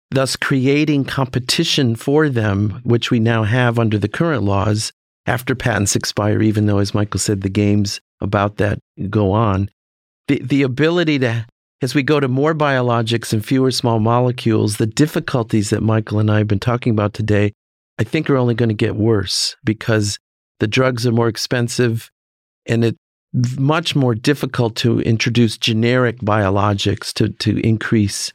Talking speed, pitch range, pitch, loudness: 165 wpm, 105-130 Hz, 115 Hz, -17 LUFS